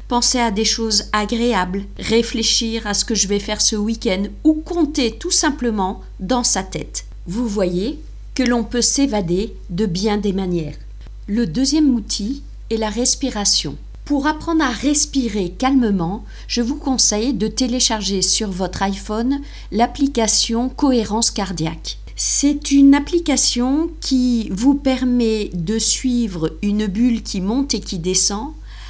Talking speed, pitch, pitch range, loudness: 140 wpm, 230 Hz, 205-260 Hz, -17 LUFS